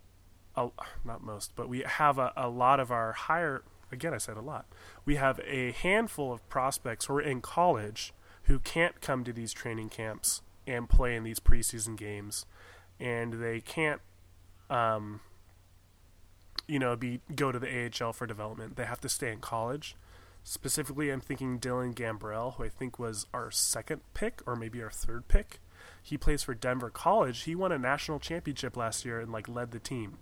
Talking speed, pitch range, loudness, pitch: 185 wpm, 105-135 Hz, -33 LUFS, 120 Hz